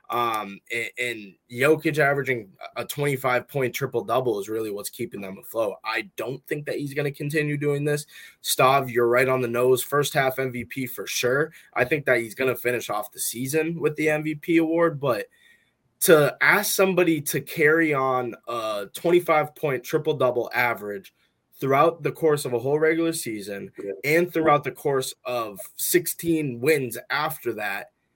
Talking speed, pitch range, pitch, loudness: 175 wpm, 120-155 Hz, 140 Hz, -24 LUFS